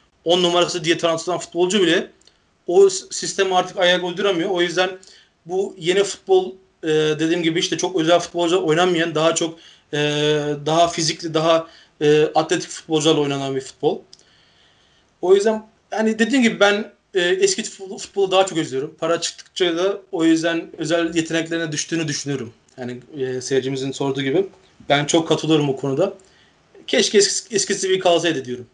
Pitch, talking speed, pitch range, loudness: 170 Hz, 140 wpm, 155-190 Hz, -19 LUFS